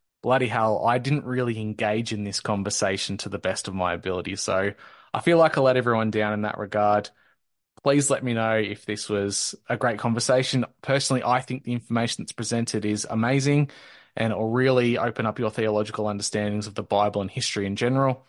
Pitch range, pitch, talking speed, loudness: 105-125 Hz, 110 Hz, 195 wpm, -24 LUFS